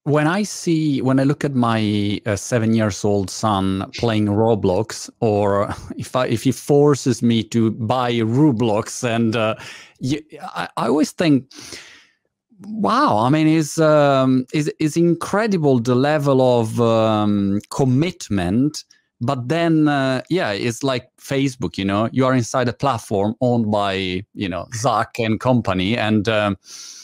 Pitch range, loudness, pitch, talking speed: 110-145 Hz, -19 LUFS, 125 Hz, 150 wpm